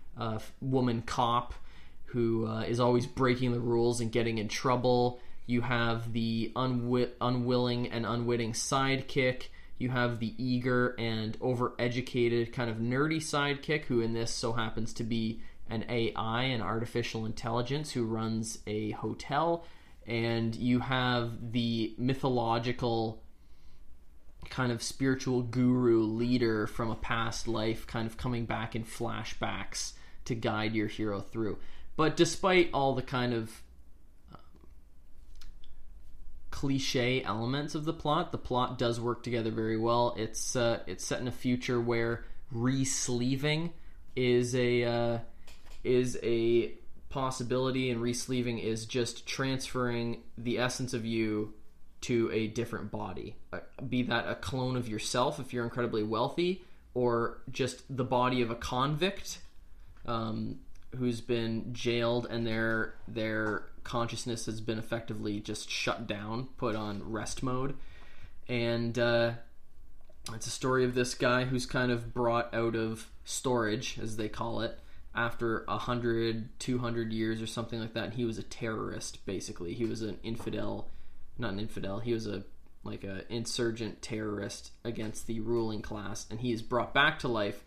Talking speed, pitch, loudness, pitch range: 150 wpm, 115 Hz, -32 LUFS, 110-125 Hz